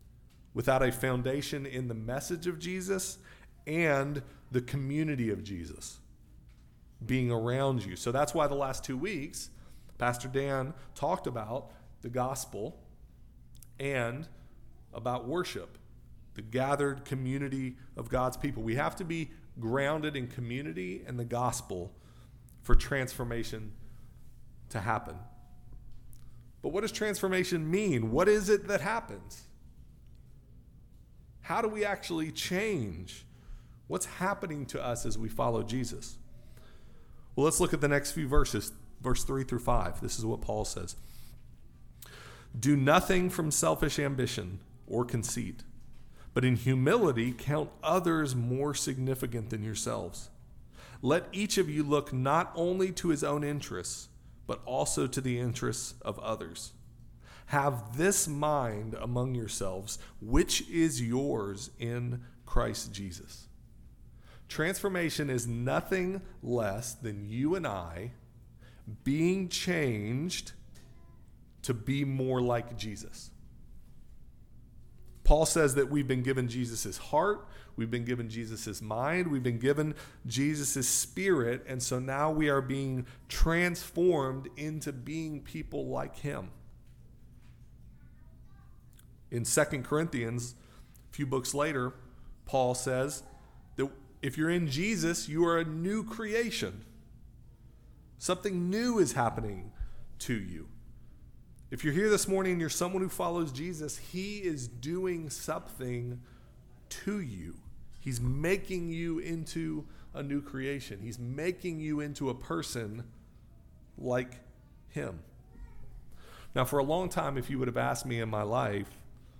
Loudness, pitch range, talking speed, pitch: -32 LUFS, 120-155 Hz, 125 wpm, 130 Hz